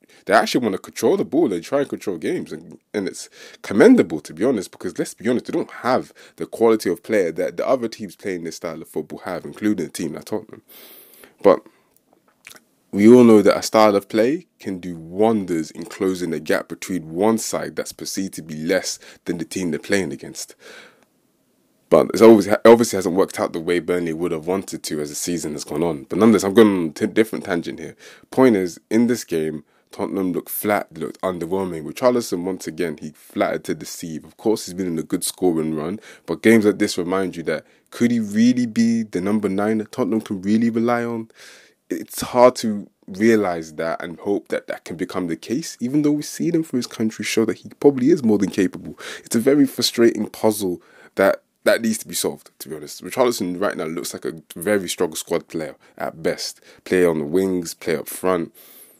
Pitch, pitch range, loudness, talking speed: 105 Hz, 90-115 Hz, -20 LUFS, 220 wpm